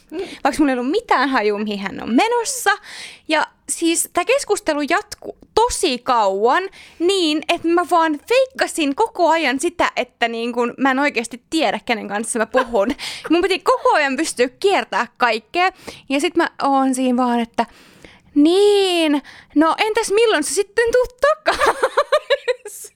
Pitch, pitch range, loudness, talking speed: 320 Hz, 255-390 Hz, -18 LUFS, 150 wpm